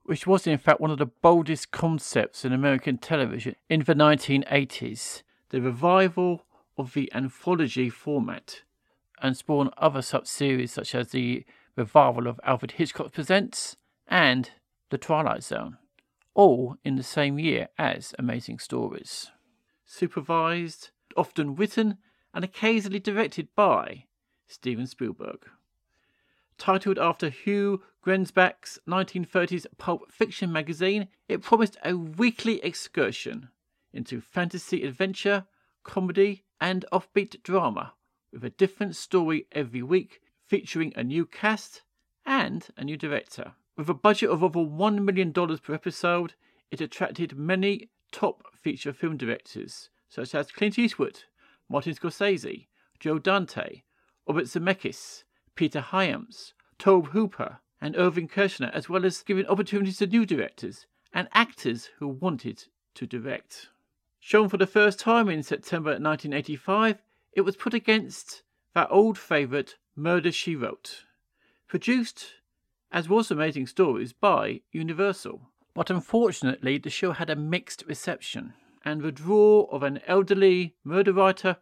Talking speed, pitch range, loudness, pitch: 130 wpm, 150-195 Hz, -26 LUFS, 175 Hz